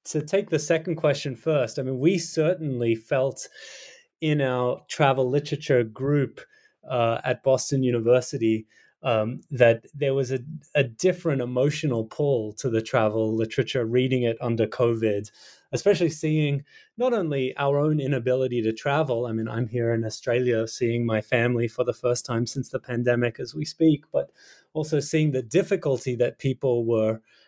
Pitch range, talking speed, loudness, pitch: 120-150 Hz, 160 wpm, -25 LUFS, 130 Hz